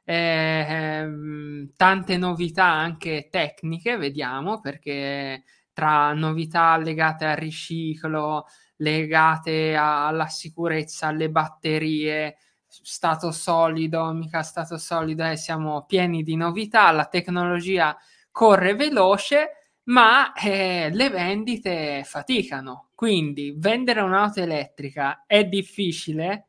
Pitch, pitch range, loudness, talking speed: 160 Hz, 155-185 Hz, -22 LUFS, 100 wpm